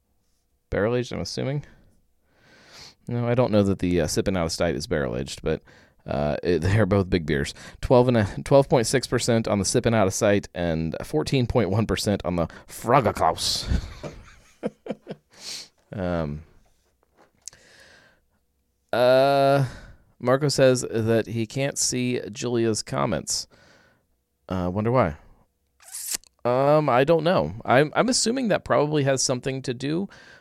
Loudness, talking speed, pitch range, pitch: -23 LUFS, 130 wpm, 90-135 Hz, 115 Hz